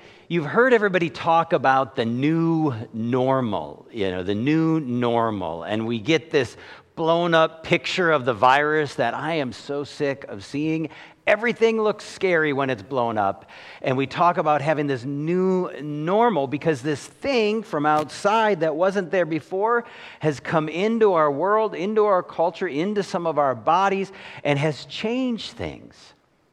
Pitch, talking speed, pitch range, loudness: 155 Hz, 160 wpm, 140-185 Hz, -22 LUFS